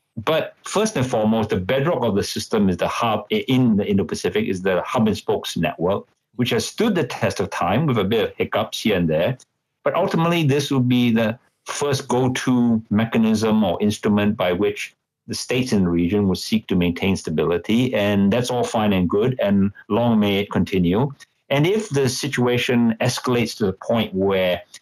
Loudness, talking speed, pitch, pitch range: -20 LUFS, 195 wpm, 110 Hz, 100-125 Hz